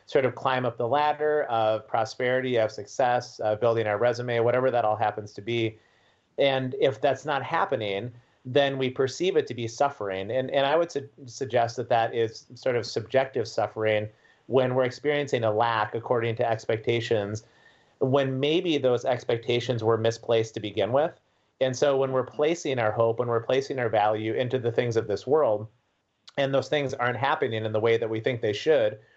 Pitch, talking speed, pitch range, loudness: 120 Hz, 190 wpm, 110-135 Hz, -26 LUFS